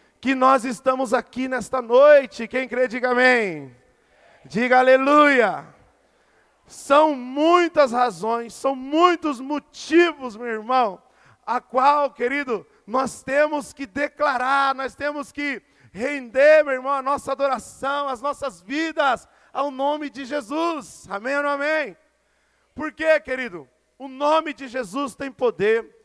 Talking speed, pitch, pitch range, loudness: 130 wpm, 275 Hz, 255-290 Hz, -21 LUFS